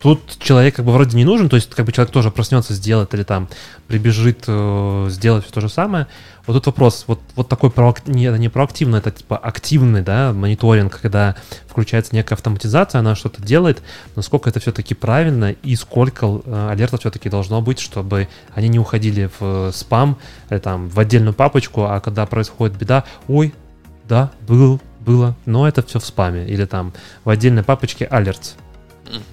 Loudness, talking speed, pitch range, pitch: -16 LUFS, 180 wpm, 105-125 Hz, 115 Hz